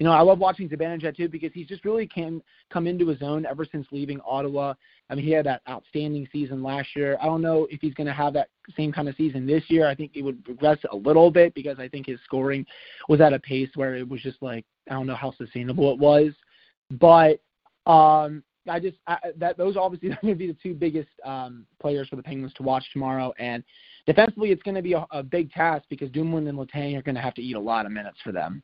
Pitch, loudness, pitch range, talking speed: 150 Hz, -24 LUFS, 135-165 Hz, 255 wpm